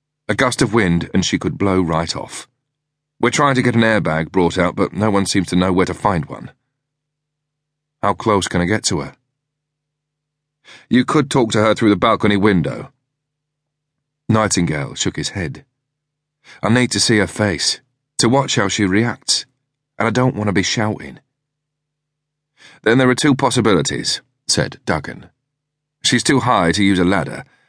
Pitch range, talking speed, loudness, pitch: 105-145 Hz, 175 wpm, -17 LUFS, 130 Hz